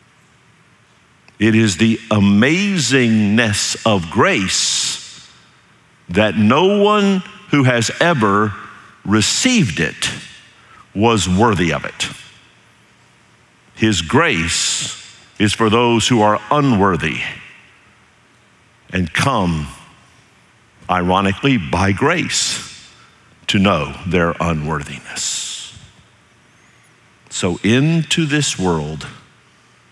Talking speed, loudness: 80 wpm, -16 LUFS